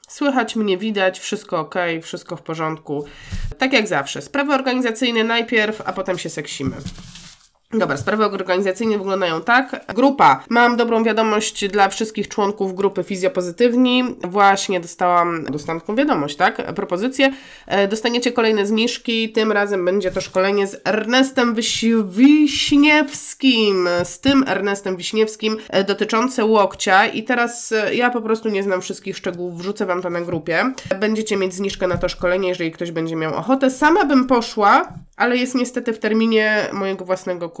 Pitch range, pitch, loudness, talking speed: 185-235 Hz, 205 Hz, -18 LUFS, 145 wpm